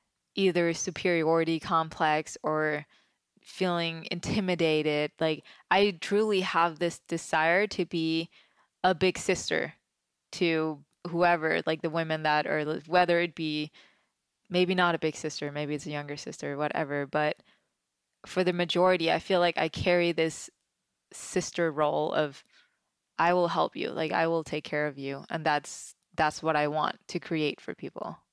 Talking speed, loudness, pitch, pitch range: 155 wpm, -28 LUFS, 165 Hz, 150-175 Hz